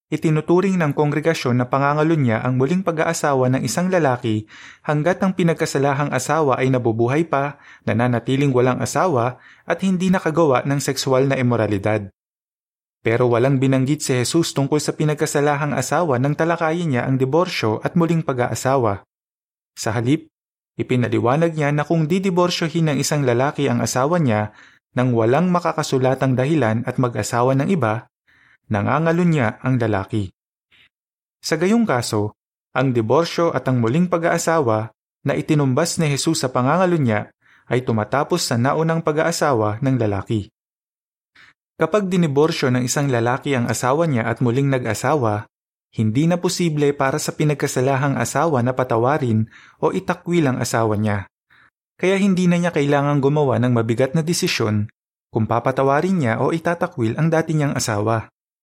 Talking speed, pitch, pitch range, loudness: 140 wpm, 135 Hz, 120-160 Hz, -19 LUFS